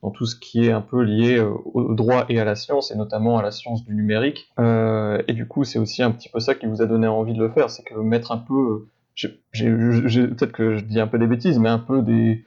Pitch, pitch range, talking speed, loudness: 115 Hz, 110-120 Hz, 285 wpm, -21 LUFS